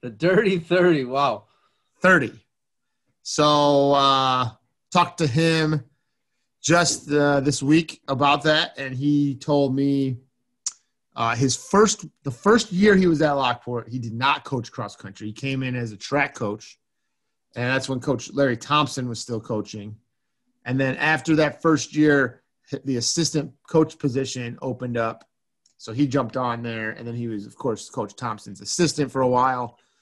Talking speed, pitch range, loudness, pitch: 160 wpm, 125-150 Hz, -22 LUFS, 135 Hz